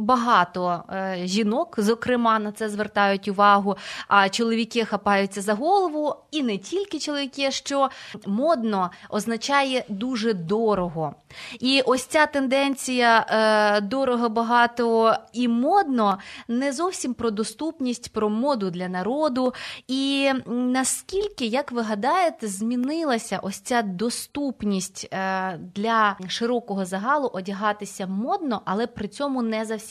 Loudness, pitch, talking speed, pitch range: -23 LUFS, 230 Hz, 120 wpm, 205-265 Hz